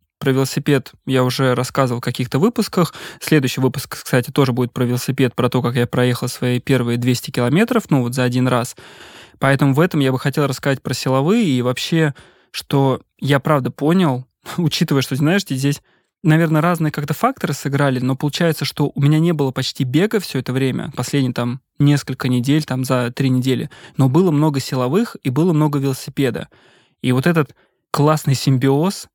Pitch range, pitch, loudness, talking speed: 130-155 Hz, 135 Hz, -18 LUFS, 175 wpm